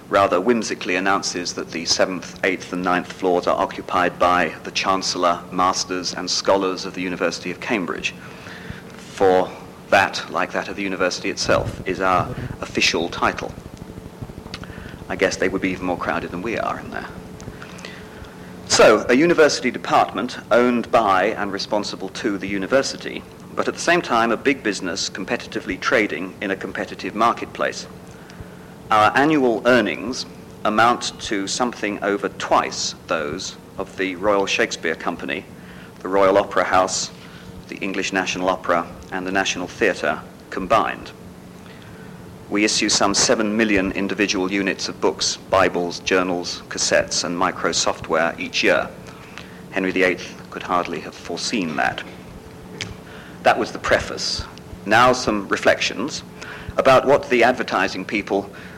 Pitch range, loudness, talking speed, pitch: 90-100 Hz, -20 LUFS, 140 wpm, 95 Hz